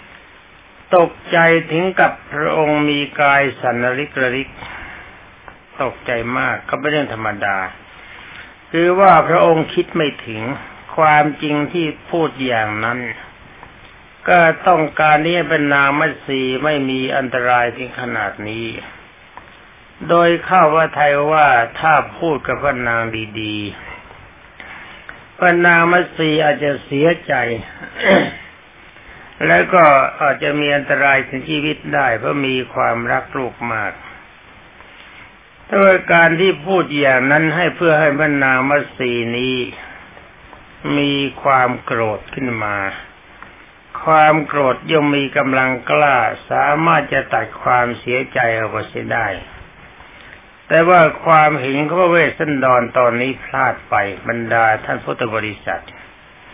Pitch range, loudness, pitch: 125-155 Hz, -15 LUFS, 145 Hz